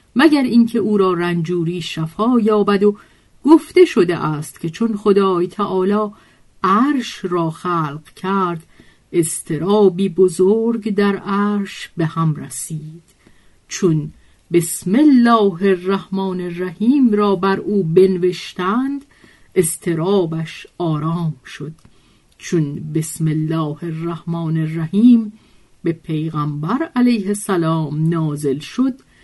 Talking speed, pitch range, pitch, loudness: 100 wpm, 165-205 Hz, 185 Hz, -17 LUFS